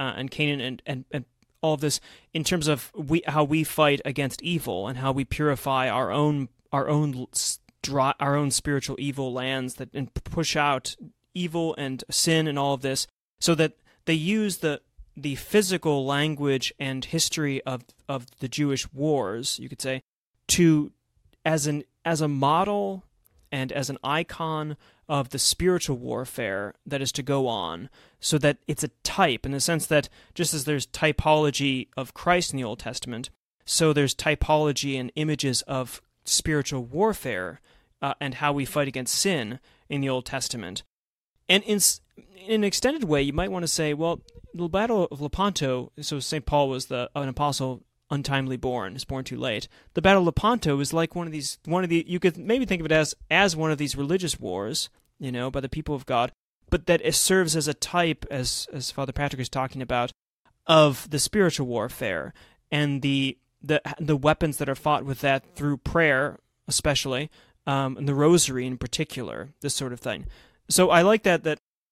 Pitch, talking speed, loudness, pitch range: 145 Hz, 185 wpm, -25 LUFS, 130-160 Hz